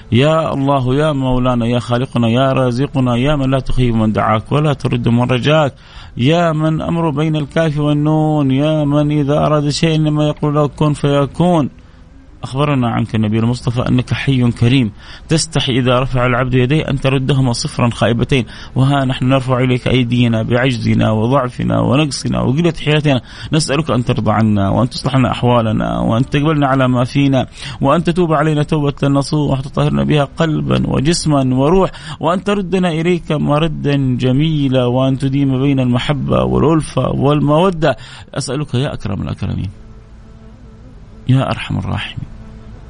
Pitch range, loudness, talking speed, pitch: 120-150 Hz, -15 LUFS, 140 wpm, 130 Hz